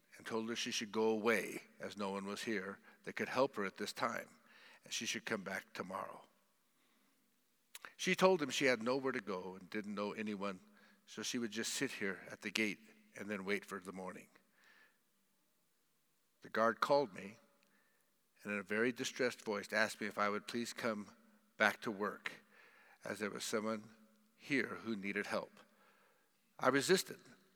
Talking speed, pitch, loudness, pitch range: 180 wpm, 110 Hz, -39 LUFS, 100-115 Hz